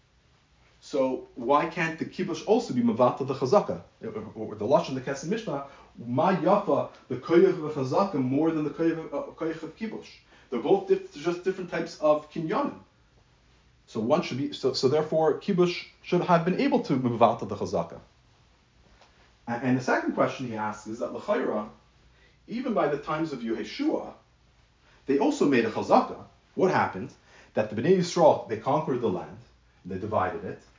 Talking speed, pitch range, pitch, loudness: 160 wpm, 130-180 Hz, 155 Hz, -27 LUFS